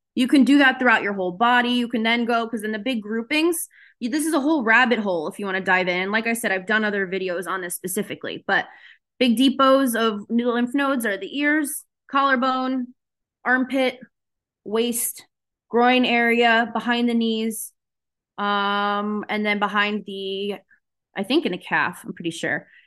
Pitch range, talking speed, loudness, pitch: 205-255 Hz, 185 wpm, -21 LUFS, 230 Hz